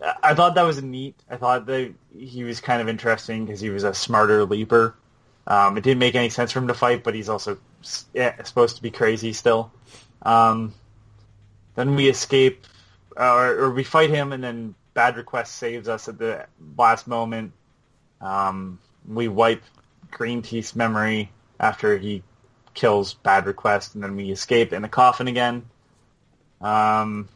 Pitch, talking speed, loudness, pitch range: 115 Hz, 170 wpm, -21 LUFS, 105-125 Hz